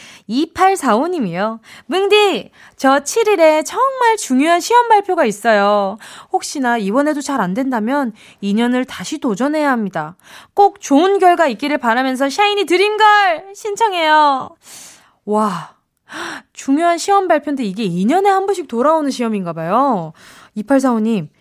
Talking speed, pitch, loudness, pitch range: 265 characters per minute, 280 Hz, -15 LUFS, 230-370 Hz